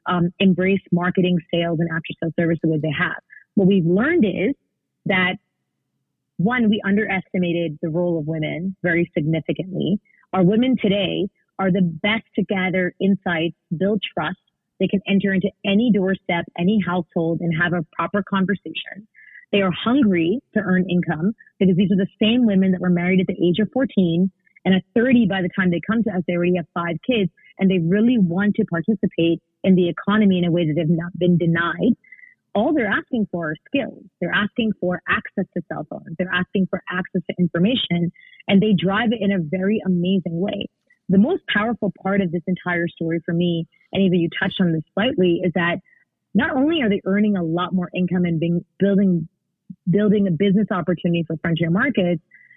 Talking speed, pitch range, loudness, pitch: 190 wpm, 175-205 Hz, -20 LUFS, 185 Hz